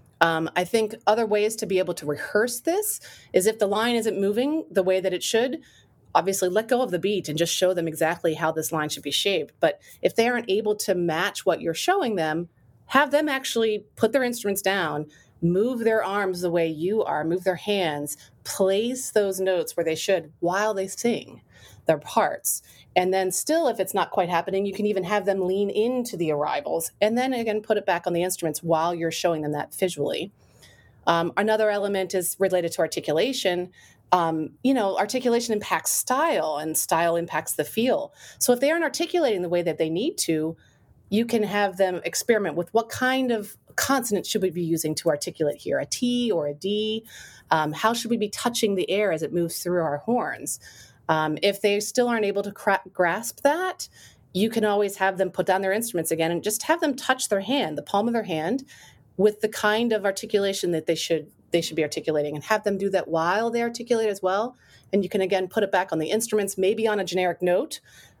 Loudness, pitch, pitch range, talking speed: -24 LUFS, 195 Hz, 170-220 Hz, 215 wpm